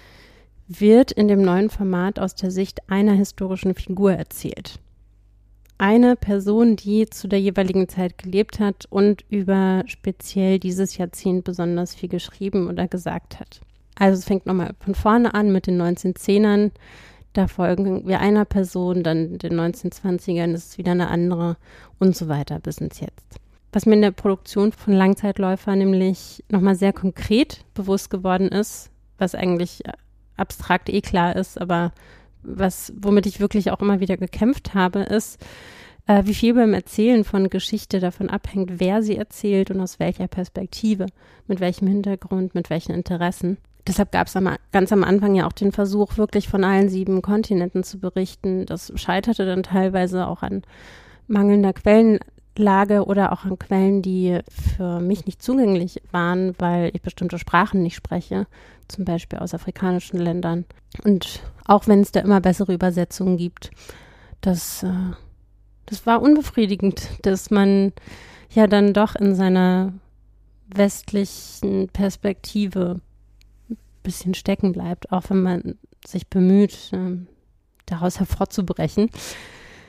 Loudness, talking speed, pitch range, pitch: -20 LUFS, 145 wpm, 180-200 Hz, 190 Hz